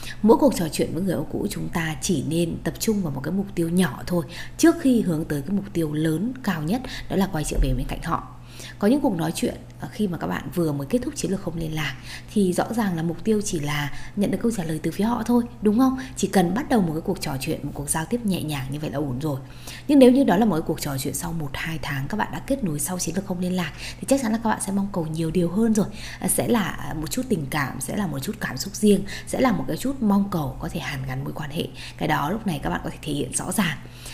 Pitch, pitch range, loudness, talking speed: 175 Hz, 150-210 Hz, -24 LUFS, 300 wpm